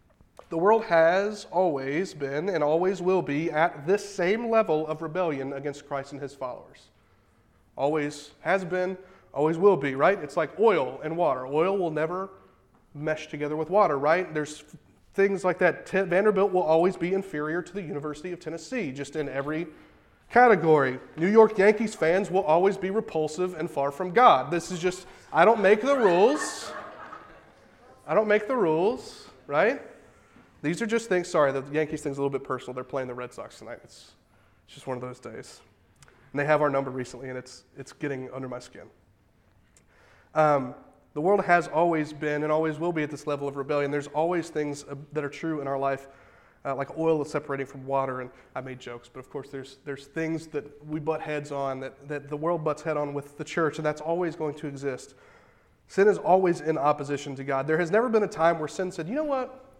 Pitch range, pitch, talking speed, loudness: 140-180 Hz, 155 Hz, 205 wpm, -26 LUFS